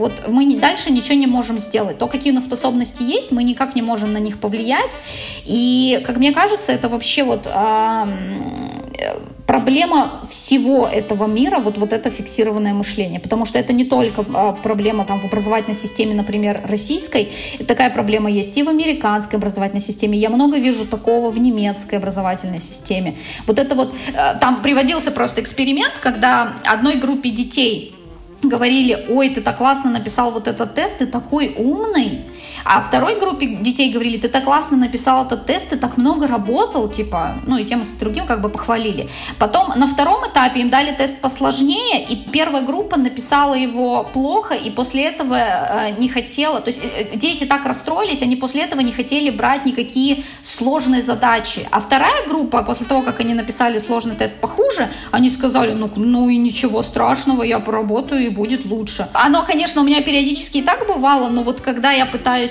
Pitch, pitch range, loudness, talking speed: 250 Hz, 225-275 Hz, -16 LUFS, 175 wpm